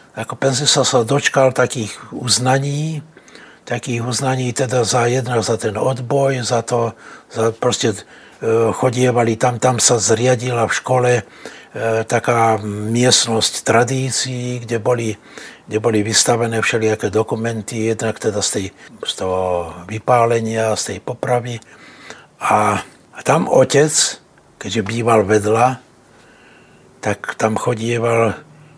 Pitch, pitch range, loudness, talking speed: 120 Hz, 115-130 Hz, -17 LUFS, 115 wpm